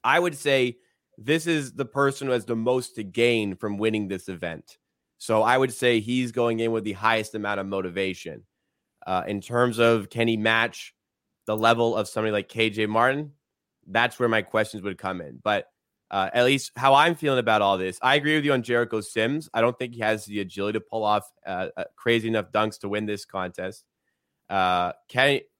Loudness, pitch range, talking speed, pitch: -24 LUFS, 105-125 Hz, 210 wpm, 115 Hz